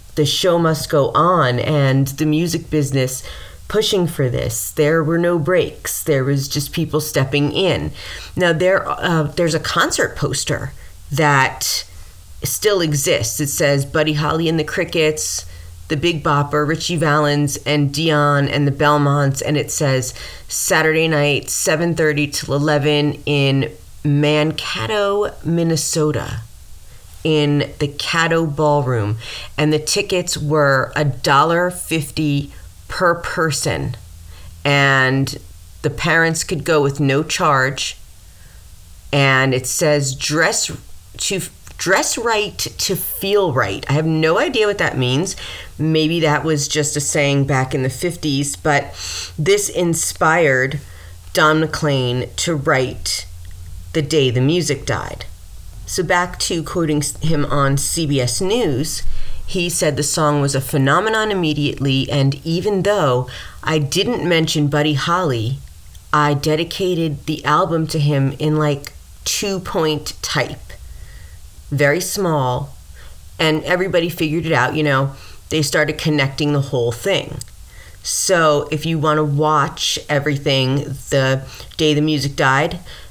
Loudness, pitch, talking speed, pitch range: -17 LUFS, 145 Hz, 130 wpm, 130-160 Hz